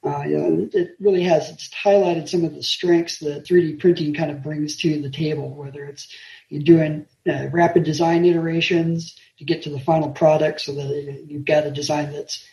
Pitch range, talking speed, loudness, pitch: 145-170 Hz, 200 wpm, -20 LUFS, 155 Hz